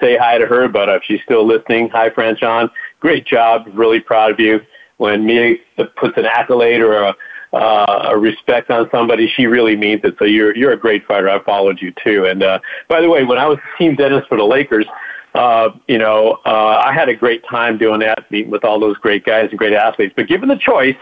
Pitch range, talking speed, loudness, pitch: 105-130 Hz, 230 wpm, -13 LUFS, 115 Hz